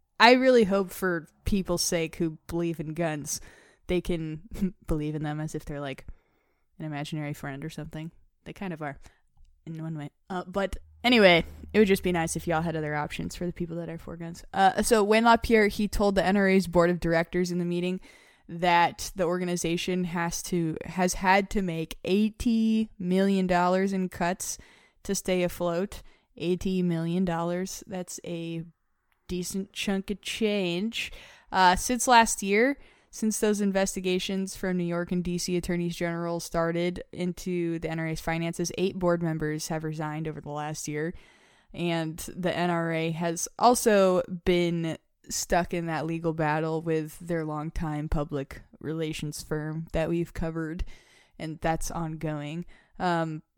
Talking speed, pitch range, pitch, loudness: 160 wpm, 160-190 Hz, 175 Hz, -27 LUFS